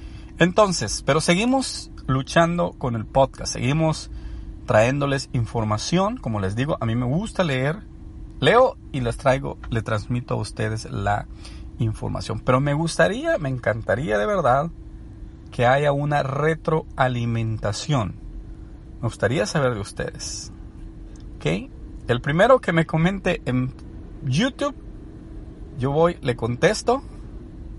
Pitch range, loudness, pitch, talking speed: 110-160 Hz, -22 LUFS, 125 Hz, 120 wpm